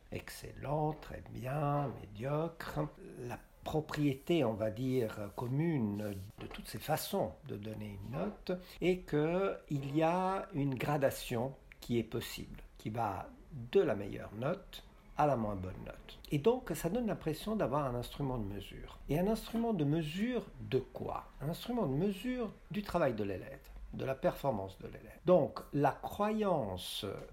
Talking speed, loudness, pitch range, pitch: 160 wpm, -37 LUFS, 115-180 Hz, 145 Hz